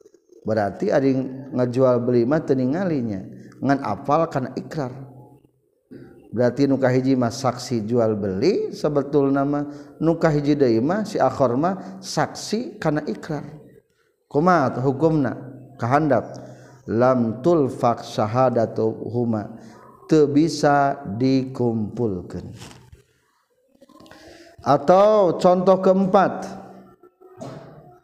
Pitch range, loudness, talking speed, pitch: 120-155 Hz, -21 LUFS, 90 wpm, 140 Hz